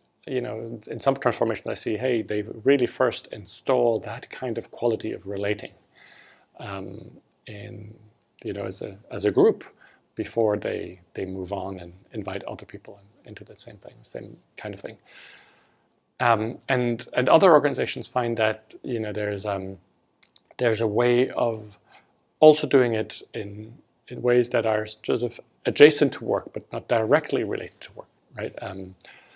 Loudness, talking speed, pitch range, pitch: -24 LUFS, 165 wpm, 105-120 Hz, 110 Hz